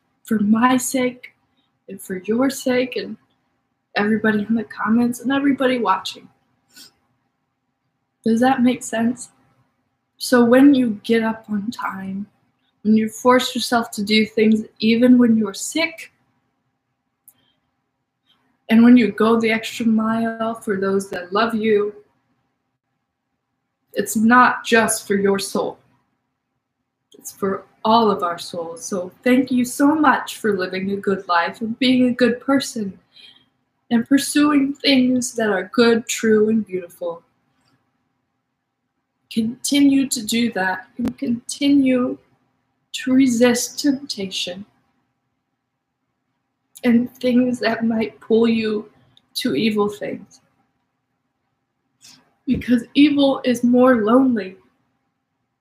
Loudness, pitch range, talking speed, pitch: -18 LUFS, 185-250 Hz, 115 wpm, 225 Hz